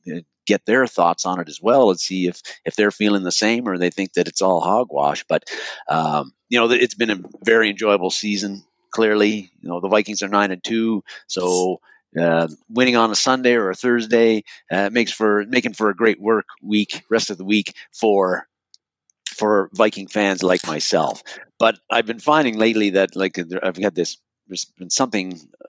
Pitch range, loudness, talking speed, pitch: 90-110 Hz, -19 LUFS, 195 wpm, 105 Hz